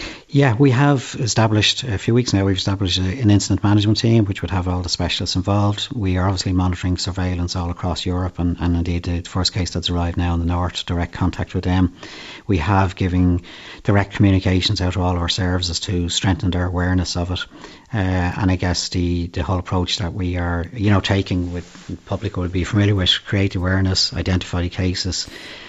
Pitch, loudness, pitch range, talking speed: 90 Hz, -19 LUFS, 90-100 Hz, 205 wpm